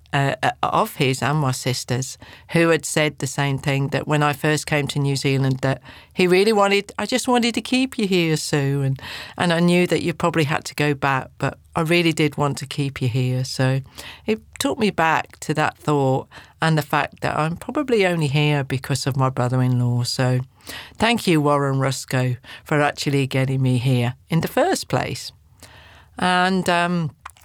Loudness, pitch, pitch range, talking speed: -21 LUFS, 145 Hz, 130-165 Hz, 195 wpm